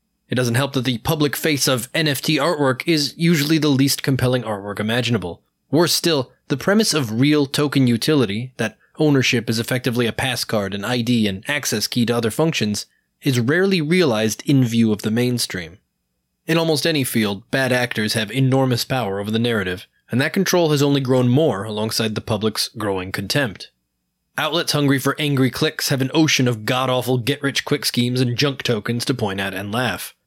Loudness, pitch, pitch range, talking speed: -19 LUFS, 130 Hz, 115-145 Hz, 180 wpm